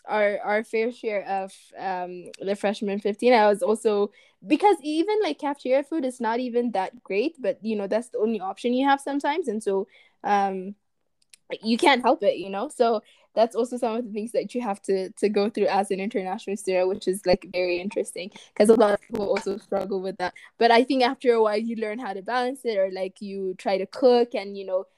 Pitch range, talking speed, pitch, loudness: 195-240 Hz, 225 wpm, 210 Hz, -25 LUFS